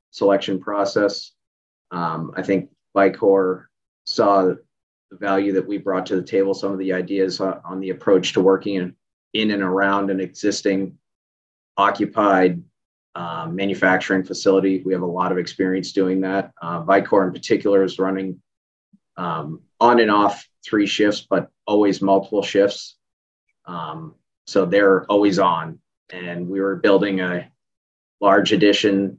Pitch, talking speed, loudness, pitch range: 95 Hz, 145 wpm, -19 LUFS, 95-100 Hz